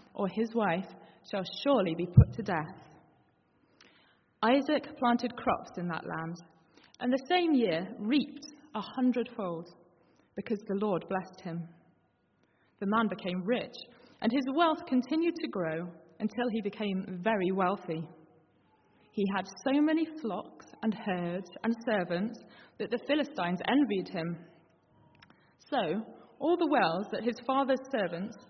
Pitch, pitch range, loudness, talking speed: 215 Hz, 175-250 Hz, -32 LUFS, 135 wpm